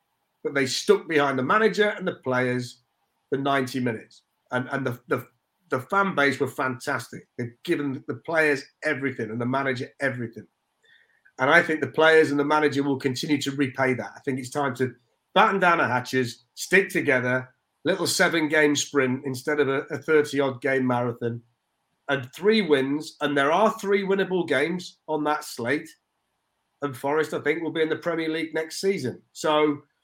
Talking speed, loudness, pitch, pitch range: 175 wpm, -24 LUFS, 140 Hz, 130-155 Hz